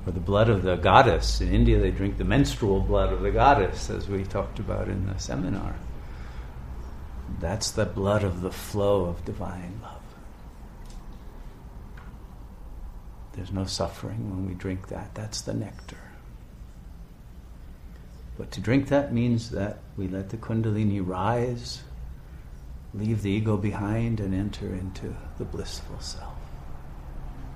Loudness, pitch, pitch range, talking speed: -27 LUFS, 95 Hz, 75-105 Hz, 140 wpm